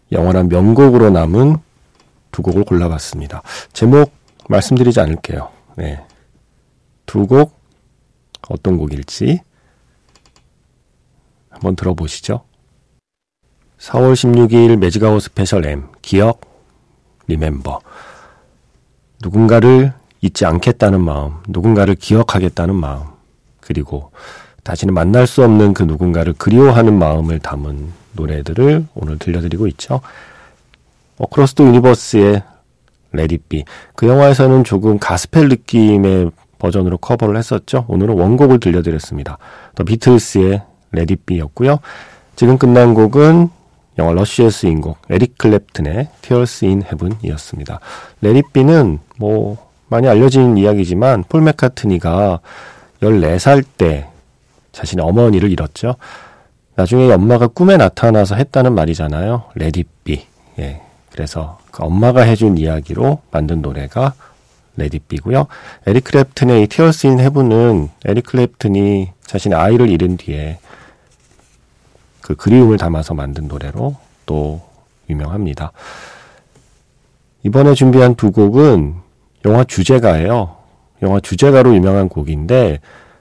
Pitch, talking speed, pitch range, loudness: 100 Hz, 270 characters per minute, 85-125 Hz, -12 LUFS